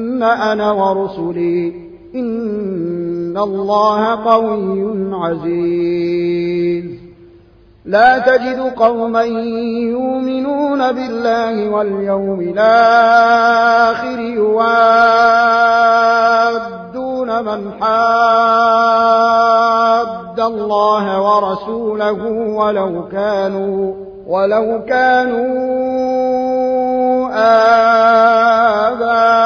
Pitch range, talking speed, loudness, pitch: 195-230 Hz, 45 wpm, -13 LUFS, 225 Hz